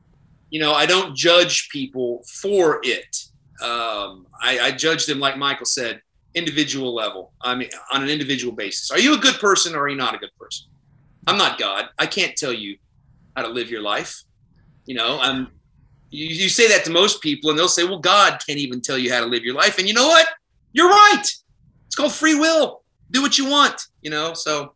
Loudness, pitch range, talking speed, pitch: -18 LUFS, 130-205 Hz, 215 wpm, 150 Hz